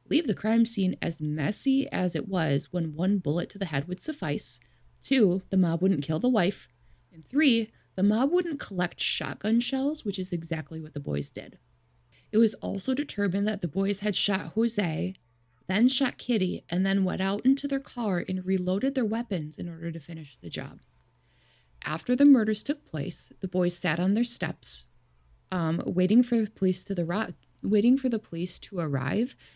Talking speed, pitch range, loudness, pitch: 190 wpm, 165-225 Hz, -28 LUFS, 190 Hz